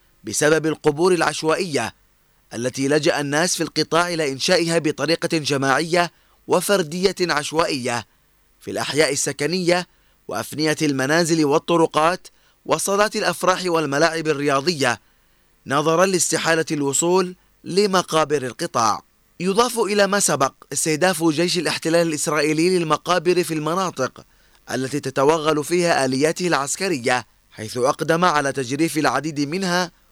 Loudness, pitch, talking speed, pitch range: -20 LUFS, 160 Hz, 100 wpm, 145-175 Hz